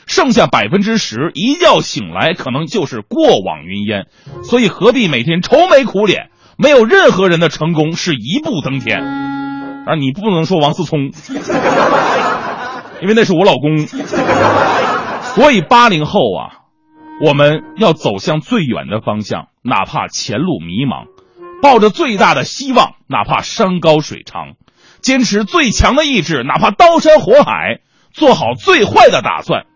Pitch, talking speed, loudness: 205 Hz, 225 characters per minute, -12 LUFS